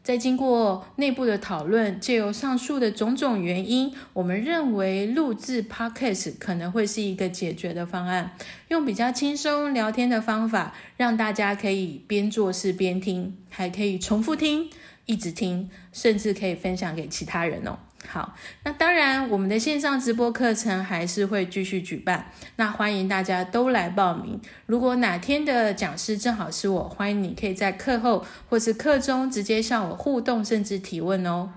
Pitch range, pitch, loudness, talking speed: 190-245 Hz, 210 Hz, -25 LUFS, 270 characters per minute